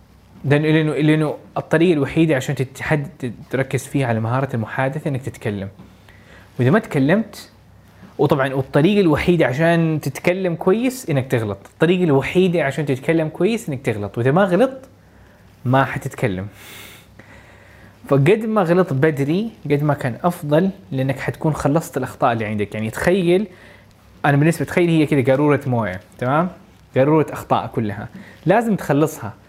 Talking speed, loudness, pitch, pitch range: 130 wpm, -19 LUFS, 135 Hz, 110-160 Hz